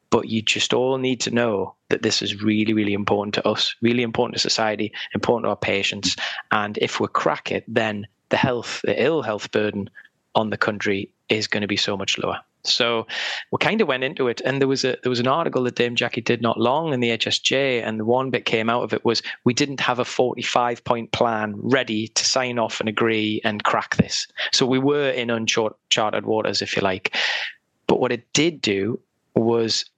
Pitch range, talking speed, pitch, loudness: 110-125 Hz, 220 wpm, 115 Hz, -22 LUFS